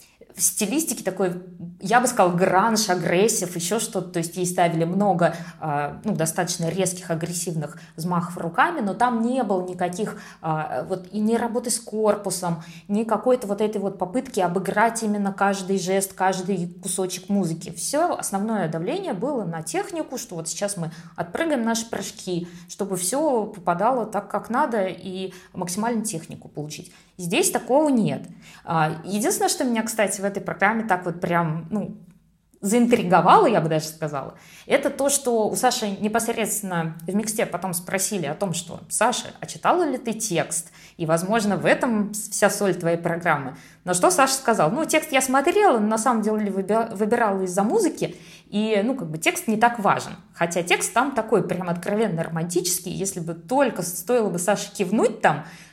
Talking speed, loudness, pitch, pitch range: 165 wpm, -23 LUFS, 195 Hz, 175-225 Hz